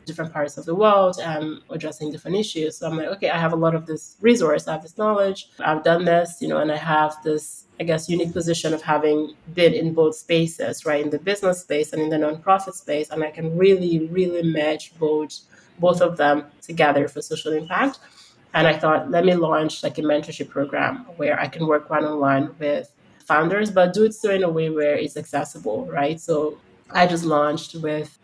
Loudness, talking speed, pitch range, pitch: -21 LUFS, 215 wpm, 150-175 Hz, 160 Hz